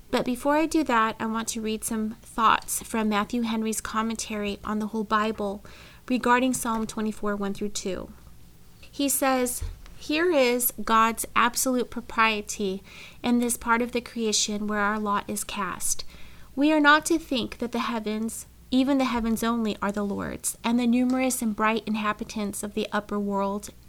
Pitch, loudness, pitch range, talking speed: 225 Hz, -26 LUFS, 210-245 Hz, 170 wpm